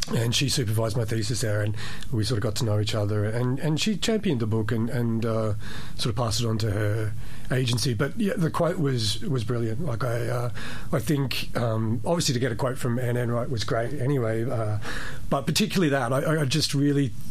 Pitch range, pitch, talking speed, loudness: 110-140 Hz, 120 Hz, 220 wpm, -26 LUFS